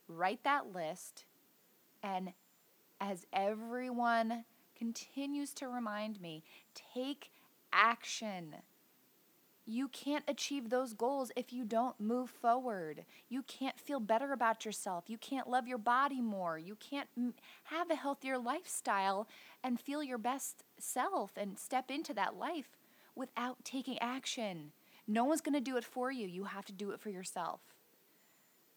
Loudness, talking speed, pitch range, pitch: -39 LUFS, 145 wpm, 215-270 Hz, 245 Hz